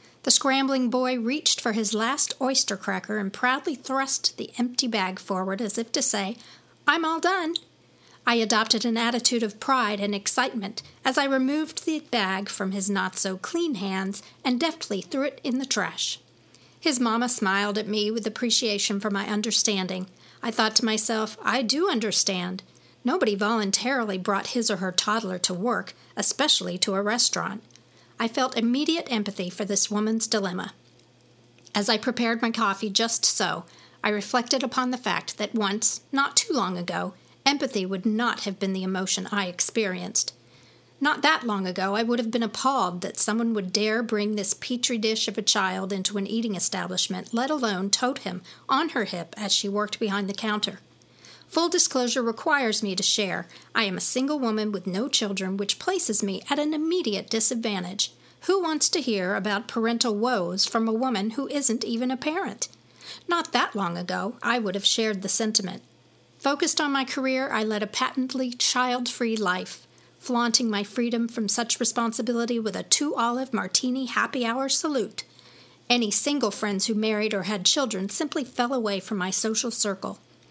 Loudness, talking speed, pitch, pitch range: -25 LUFS, 175 wpm, 225 Hz, 200-255 Hz